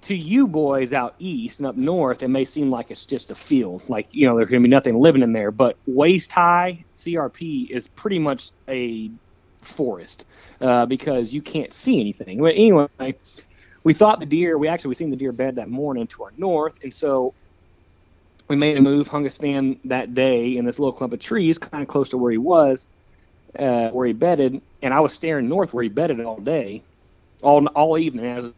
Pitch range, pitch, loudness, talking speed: 120-155 Hz, 130 Hz, -20 LUFS, 215 wpm